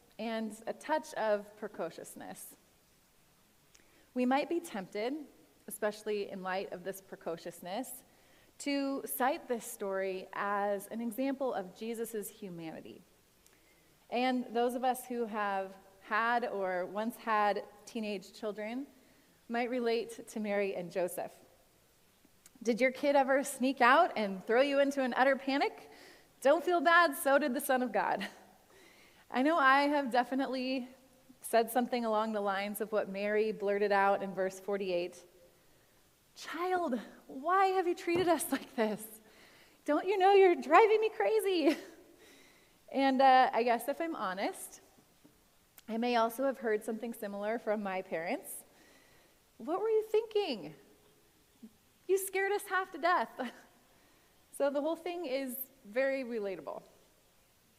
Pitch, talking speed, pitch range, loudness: 240 Hz, 135 wpm, 205-275 Hz, -33 LUFS